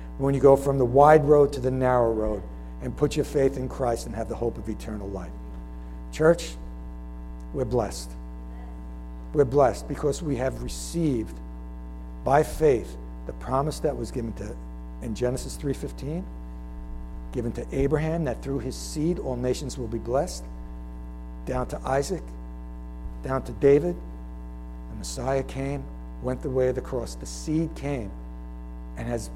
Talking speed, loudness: 155 wpm, -26 LUFS